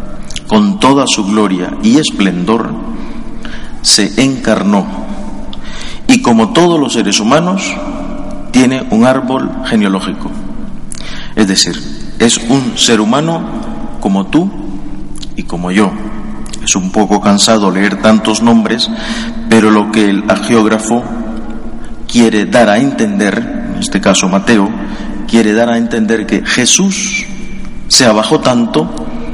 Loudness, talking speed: -10 LUFS, 120 wpm